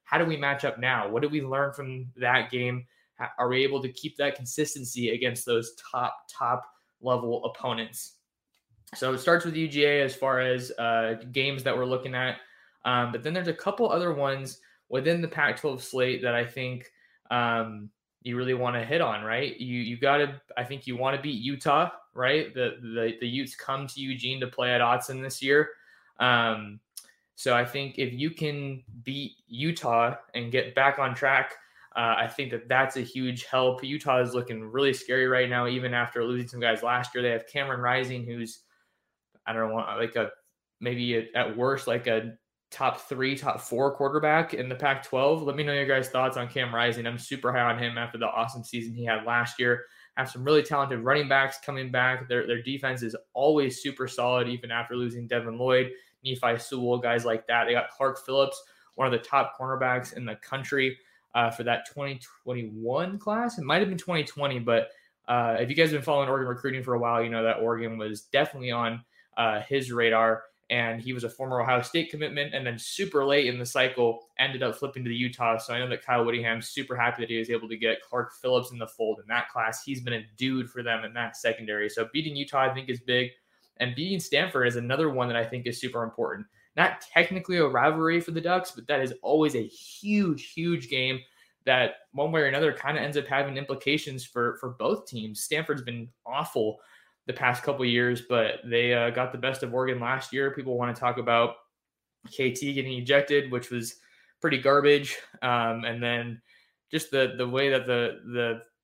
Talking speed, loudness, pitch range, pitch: 210 wpm, -27 LUFS, 120-140 Hz, 125 Hz